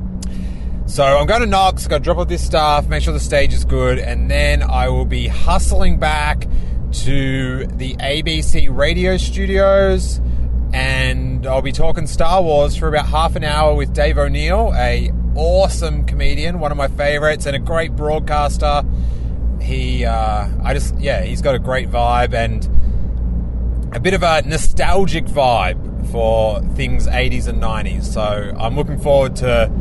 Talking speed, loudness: 165 wpm, -17 LUFS